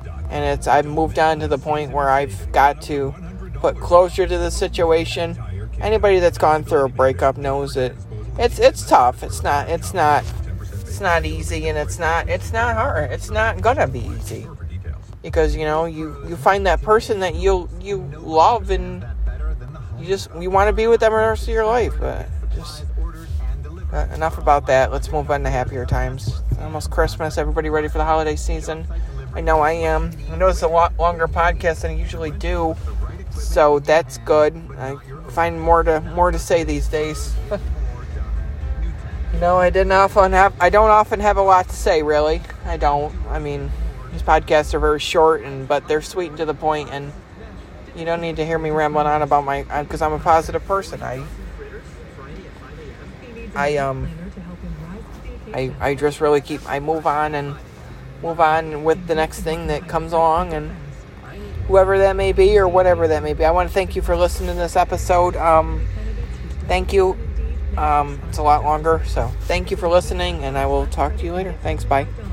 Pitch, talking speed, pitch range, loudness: 150 Hz, 190 wpm, 100-165 Hz, -19 LUFS